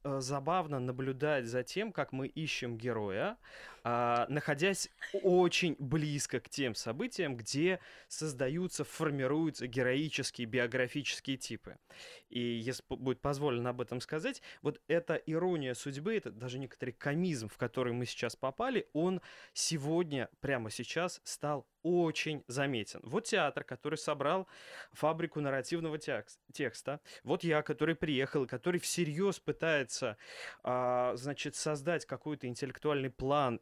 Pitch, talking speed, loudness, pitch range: 145 Hz, 120 wpm, -36 LUFS, 125-160 Hz